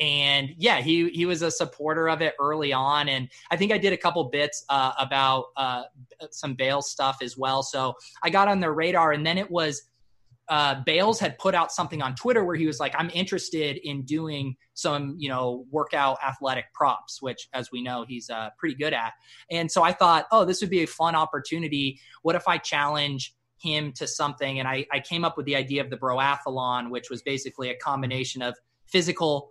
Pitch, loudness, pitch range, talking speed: 145 Hz, -25 LUFS, 130-165 Hz, 210 wpm